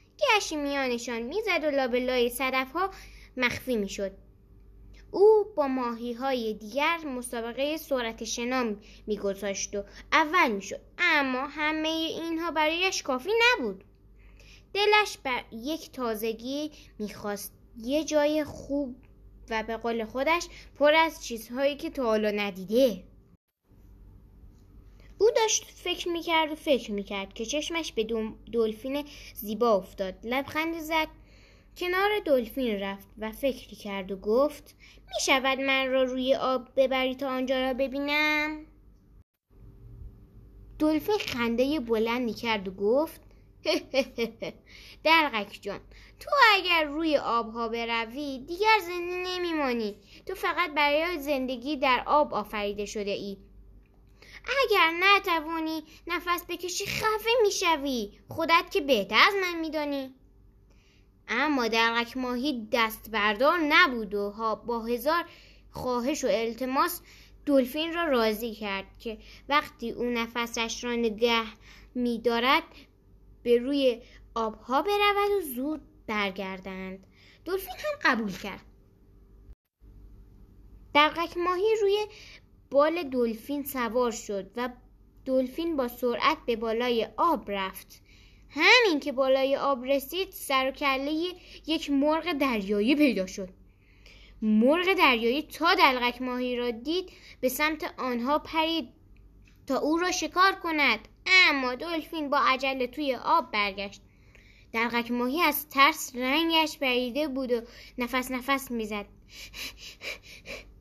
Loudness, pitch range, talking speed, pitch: -27 LUFS, 225-315 Hz, 115 wpm, 260 Hz